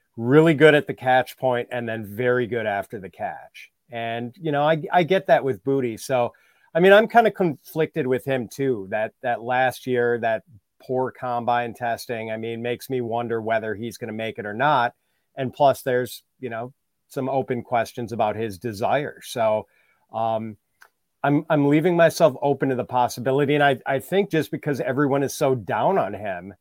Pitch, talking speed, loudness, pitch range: 125 Hz, 190 wpm, -22 LUFS, 115-145 Hz